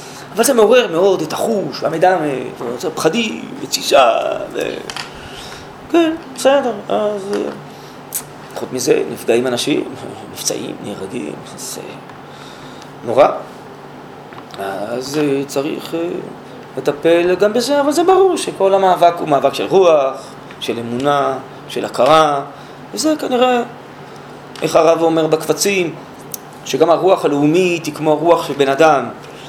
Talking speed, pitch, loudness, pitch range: 110 wpm, 165 Hz, -15 LUFS, 140-210 Hz